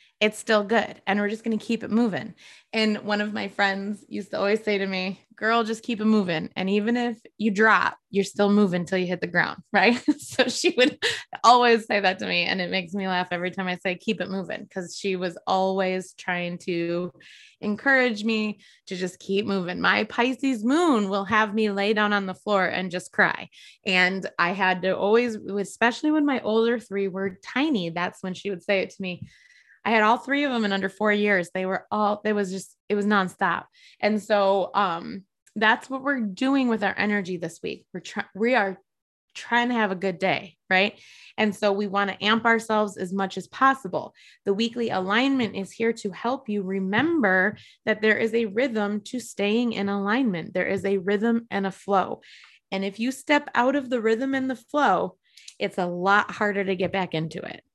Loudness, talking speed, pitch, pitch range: -24 LUFS, 215 wpm, 205 Hz, 190-230 Hz